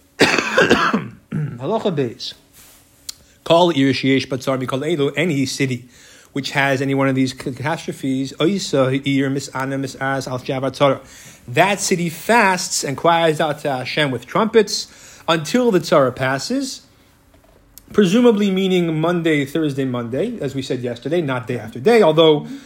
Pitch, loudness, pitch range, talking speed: 145 Hz, -18 LUFS, 135-175 Hz, 115 wpm